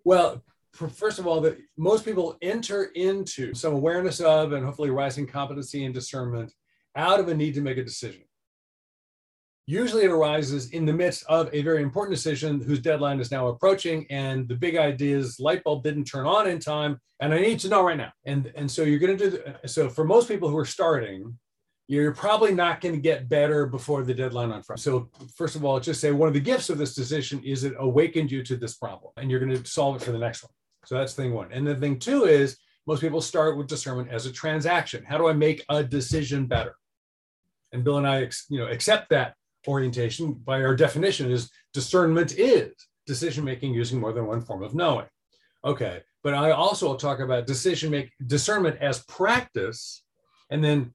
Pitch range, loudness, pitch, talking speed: 130-160 Hz, -25 LUFS, 145 Hz, 210 wpm